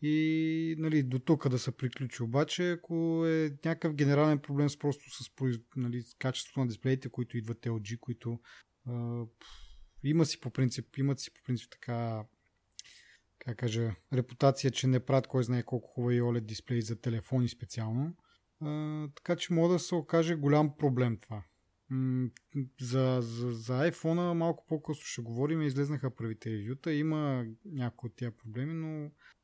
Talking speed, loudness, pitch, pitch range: 165 wpm, -33 LUFS, 130 Hz, 120-150 Hz